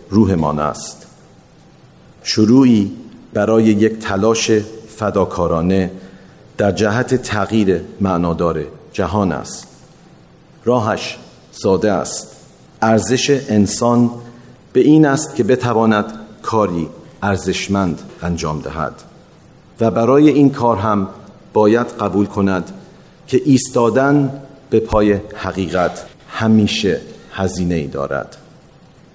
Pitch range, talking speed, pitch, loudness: 95-120 Hz, 95 wpm, 105 Hz, -16 LUFS